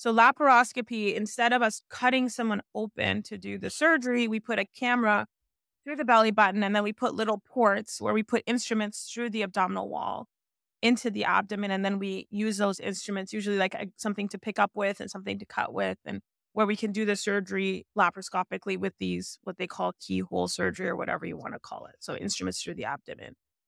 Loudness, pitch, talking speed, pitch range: -28 LUFS, 210 Hz, 210 wpm, 195-230 Hz